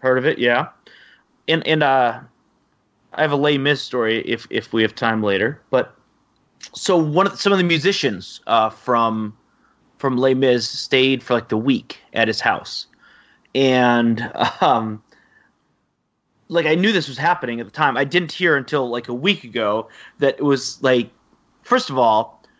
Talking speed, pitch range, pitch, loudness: 180 wpm, 115-155 Hz, 130 Hz, -19 LUFS